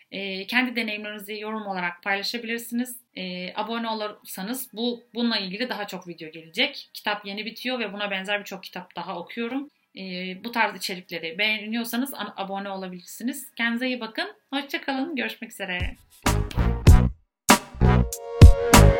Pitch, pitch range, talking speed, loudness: 210 Hz, 185-235 Hz, 115 wpm, -25 LUFS